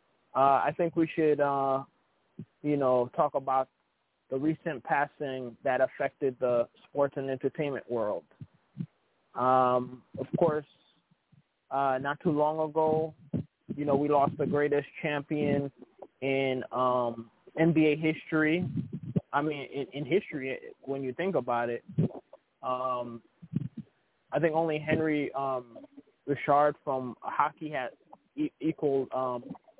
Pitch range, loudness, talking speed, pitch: 130-155 Hz, -30 LUFS, 125 wpm, 145 Hz